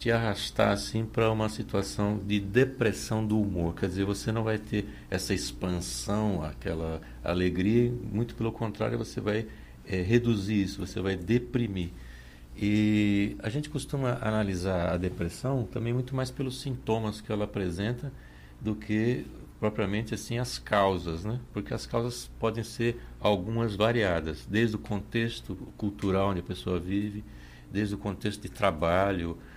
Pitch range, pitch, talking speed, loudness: 95-115 Hz, 105 Hz, 150 wpm, -30 LUFS